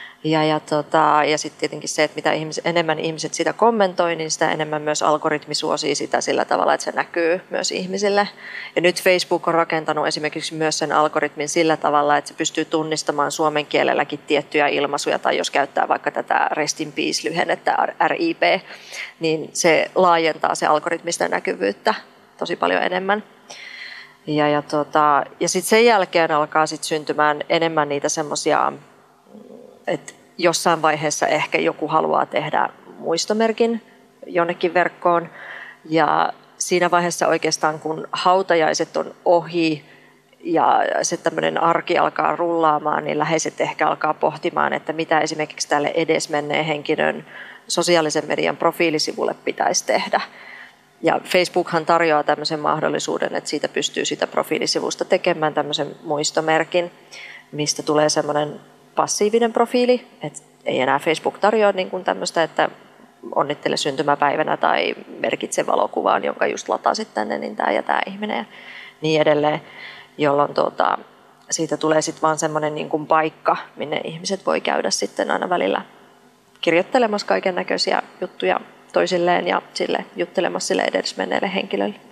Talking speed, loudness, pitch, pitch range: 140 wpm, -20 LUFS, 160 Hz, 150-175 Hz